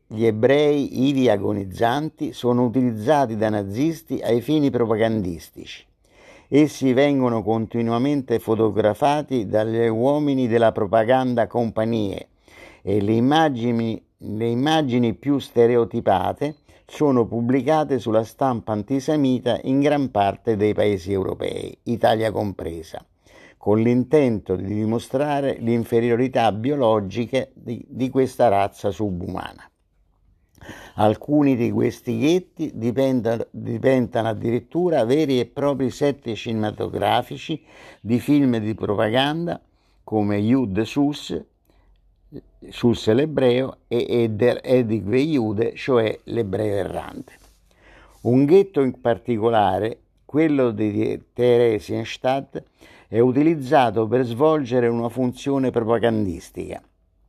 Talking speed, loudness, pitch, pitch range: 95 wpm, -21 LUFS, 120 Hz, 110-135 Hz